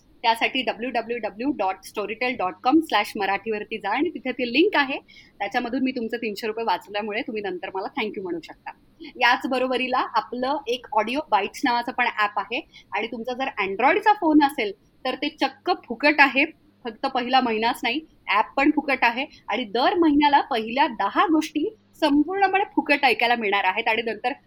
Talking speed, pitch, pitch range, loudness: 175 wpm, 255 Hz, 225-295 Hz, -23 LUFS